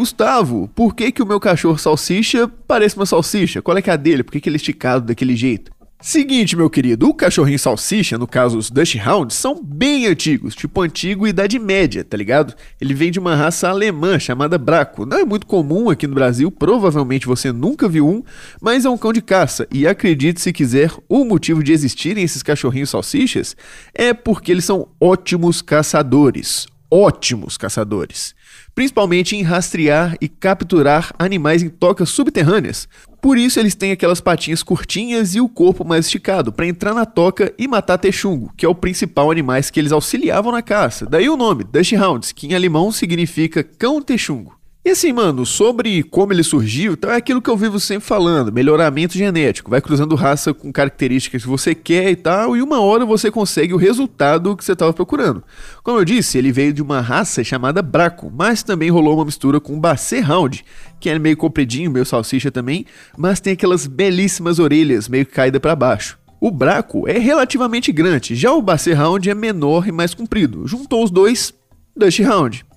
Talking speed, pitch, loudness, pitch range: 190 wpm, 175 Hz, -15 LUFS, 150-210 Hz